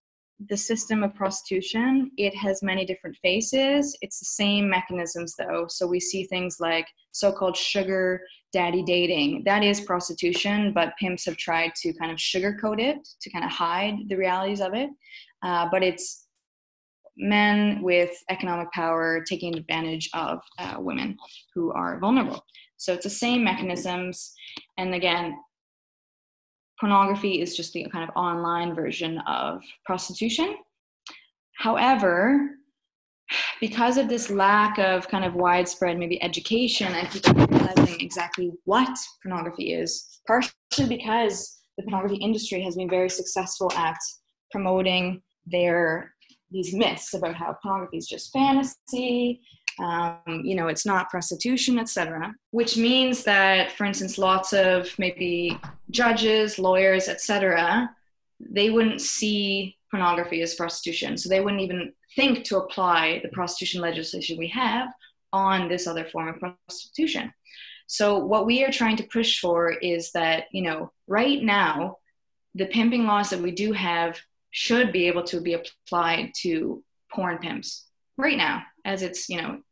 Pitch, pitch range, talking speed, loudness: 190 Hz, 175-225 Hz, 145 wpm, -24 LUFS